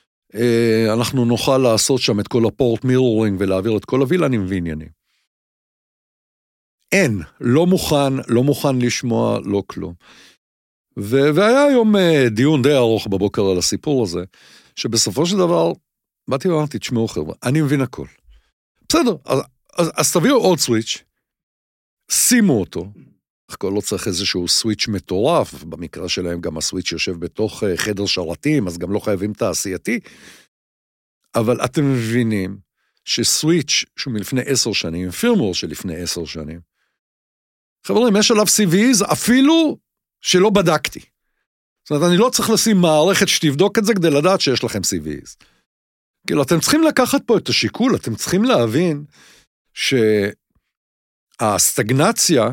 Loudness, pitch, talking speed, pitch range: -17 LUFS, 120 Hz, 130 wpm, 100-160 Hz